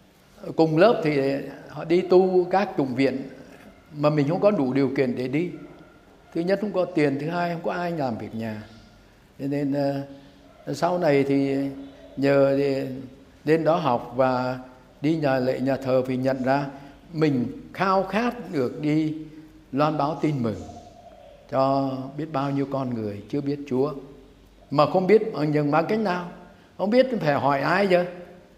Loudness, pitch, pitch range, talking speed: -24 LUFS, 140 Hz, 135-170 Hz, 175 wpm